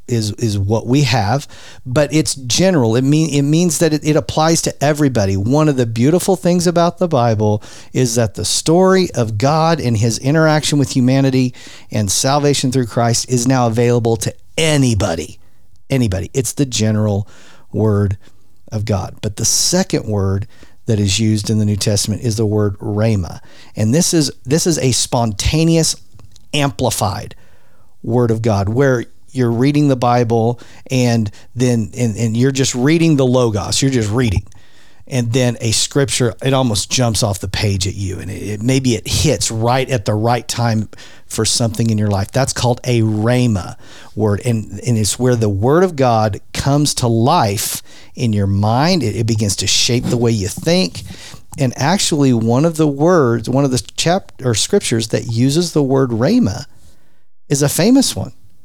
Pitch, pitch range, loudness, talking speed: 120 Hz, 105-140 Hz, -15 LUFS, 175 wpm